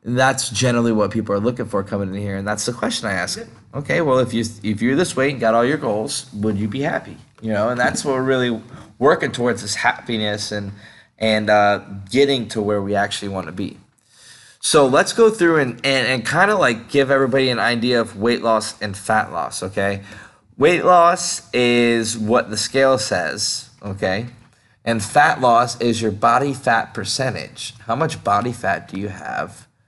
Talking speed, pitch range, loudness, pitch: 200 wpm, 105-130 Hz, -18 LUFS, 115 Hz